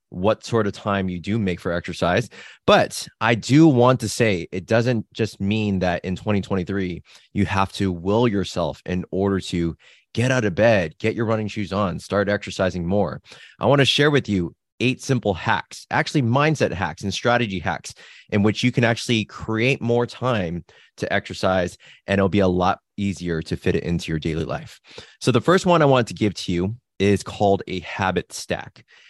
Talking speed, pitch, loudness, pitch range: 195 wpm, 100 Hz, -21 LUFS, 95-115 Hz